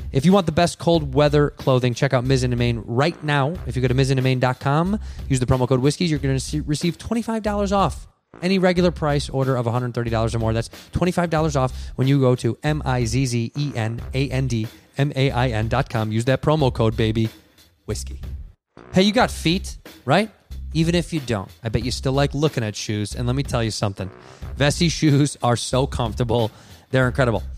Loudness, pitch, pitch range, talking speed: -21 LUFS, 130 Hz, 115-150 Hz, 205 wpm